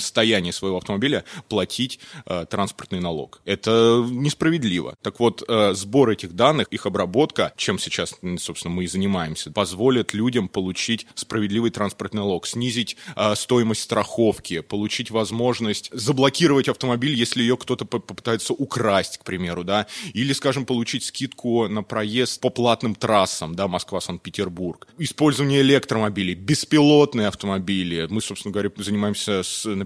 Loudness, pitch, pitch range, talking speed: -22 LUFS, 110 Hz, 100-125 Hz, 135 wpm